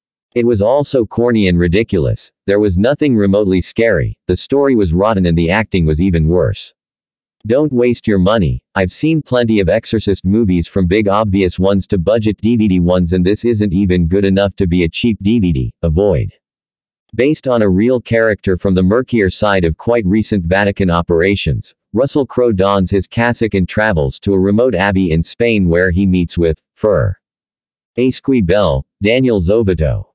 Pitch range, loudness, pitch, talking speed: 90-115 Hz, -14 LUFS, 100 Hz, 170 wpm